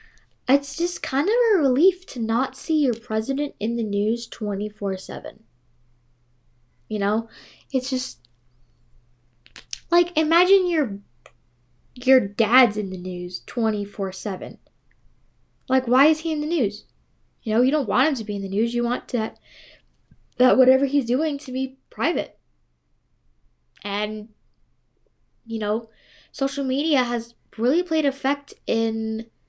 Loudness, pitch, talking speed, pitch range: -23 LUFS, 230 Hz, 135 wpm, 200-275 Hz